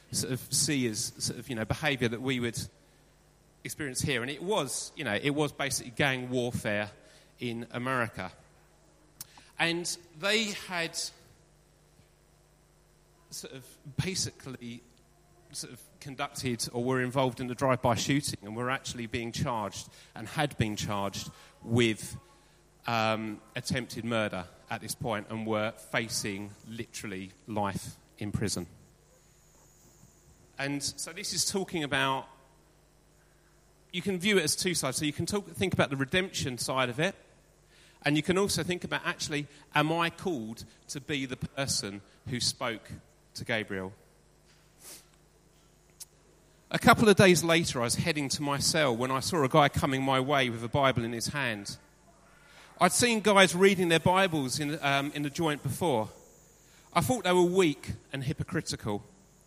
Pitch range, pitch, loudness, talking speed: 120-165 Hz, 135 Hz, -29 LUFS, 155 wpm